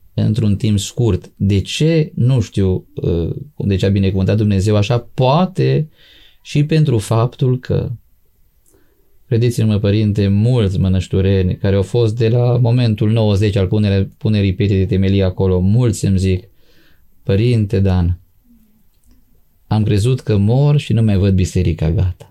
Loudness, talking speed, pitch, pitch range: -15 LUFS, 140 wpm, 105 Hz, 95-120 Hz